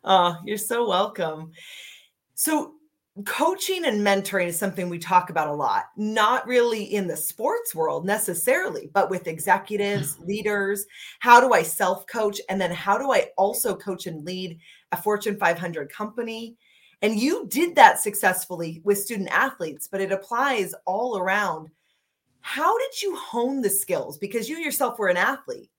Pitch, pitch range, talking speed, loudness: 205 Hz, 185-240 Hz, 160 wpm, -23 LUFS